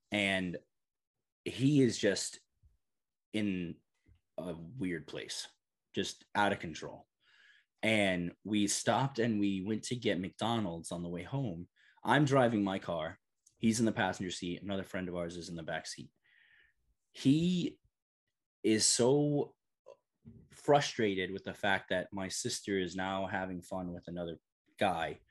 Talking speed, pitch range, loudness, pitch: 140 wpm, 90-115 Hz, -34 LUFS, 95 Hz